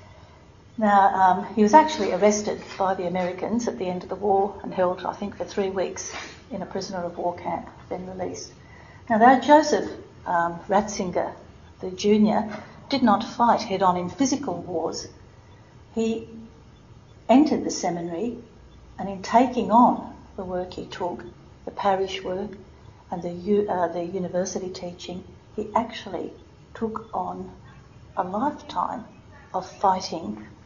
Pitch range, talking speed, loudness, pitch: 180-225 Hz, 145 wpm, -24 LUFS, 195 Hz